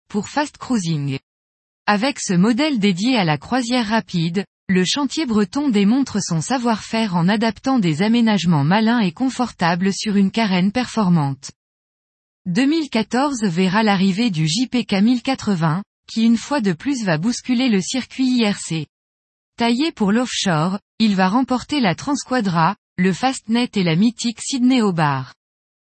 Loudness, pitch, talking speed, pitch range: -19 LUFS, 215 Hz, 135 wpm, 180-250 Hz